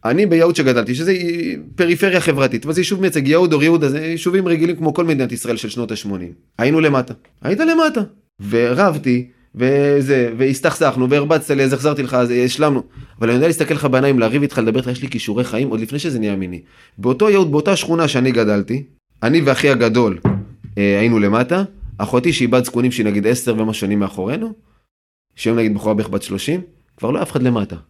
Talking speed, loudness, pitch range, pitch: 170 wpm, -16 LUFS, 115-160 Hz, 130 Hz